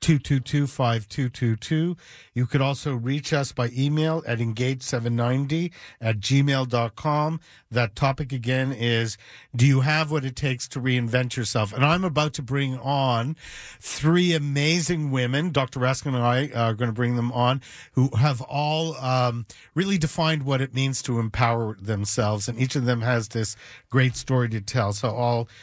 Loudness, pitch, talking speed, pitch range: -24 LUFS, 130 Hz, 175 wpm, 120-145 Hz